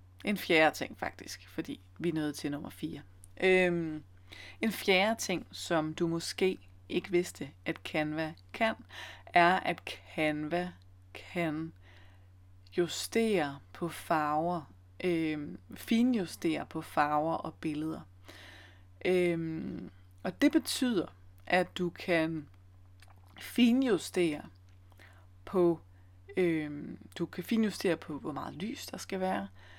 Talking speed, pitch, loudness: 115 wpm, 155 Hz, -32 LUFS